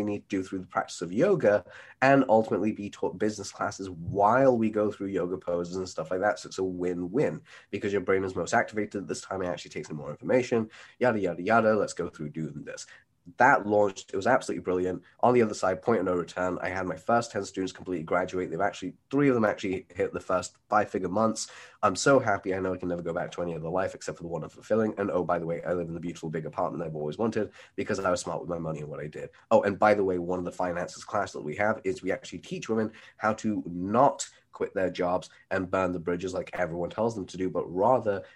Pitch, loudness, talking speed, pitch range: 95 Hz, -28 LUFS, 260 wpm, 90-105 Hz